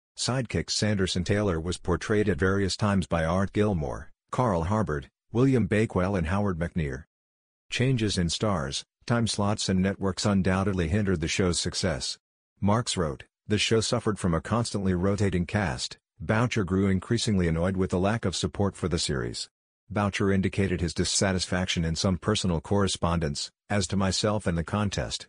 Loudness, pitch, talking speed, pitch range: -27 LUFS, 95 Hz, 155 wpm, 90-105 Hz